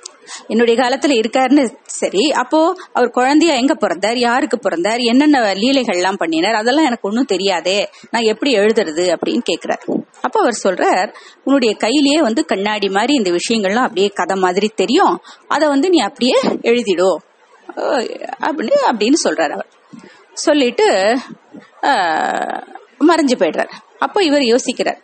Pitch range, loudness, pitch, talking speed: 205-300 Hz, -15 LUFS, 250 Hz, 125 wpm